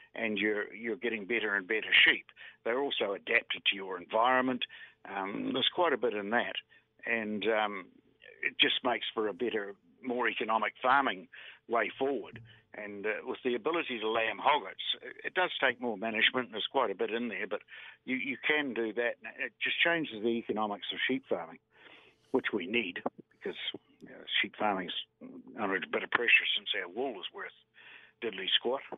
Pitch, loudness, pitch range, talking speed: 115 Hz, -31 LUFS, 110-135 Hz, 185 wpm